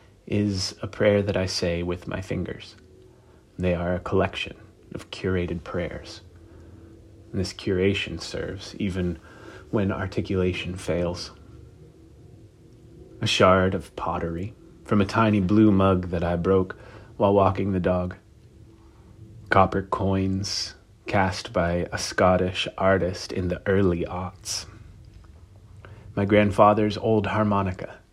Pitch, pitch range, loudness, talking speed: 95 Hz, 90-105 Hz, -24 LUFS, 115 wpm